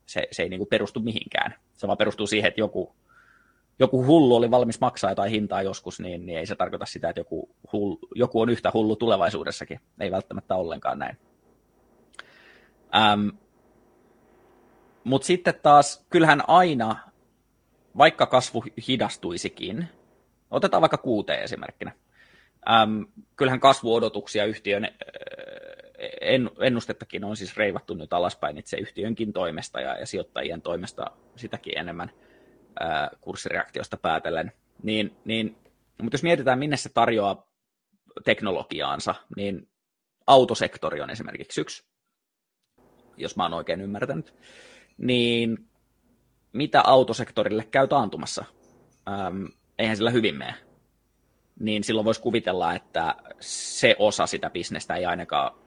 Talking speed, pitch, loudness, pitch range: 125 wpm, 115 Hz, -24 LUFS, 105-135 Hz